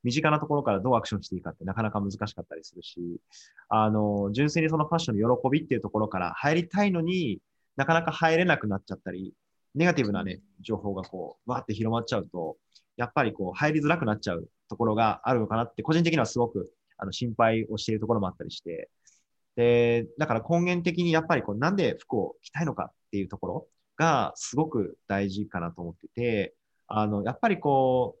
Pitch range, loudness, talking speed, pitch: 100-150 Hz, -27 LUFS, 445 characters per minute, 115 Hz